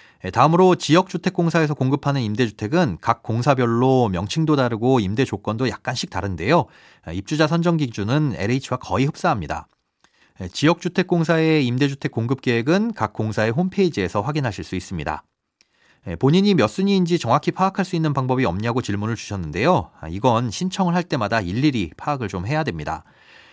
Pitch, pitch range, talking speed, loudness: 130 Hz, 110-165 Hz, 380 characters per minute, -21 LUFS